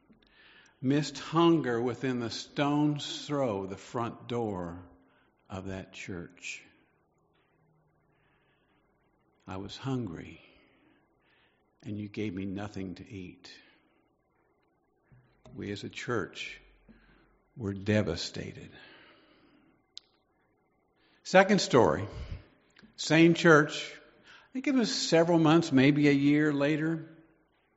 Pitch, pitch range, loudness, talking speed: 130 Hz, 100-150 Hz, -28 LUFS, 90 wpm